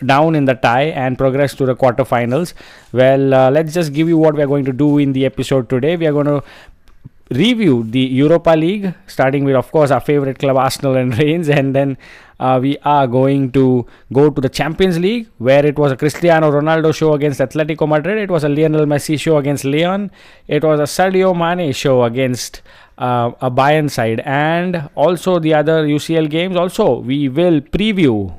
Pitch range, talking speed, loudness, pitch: 130-160 Hz, 200 wpm, -14 LUFS, 145 Hz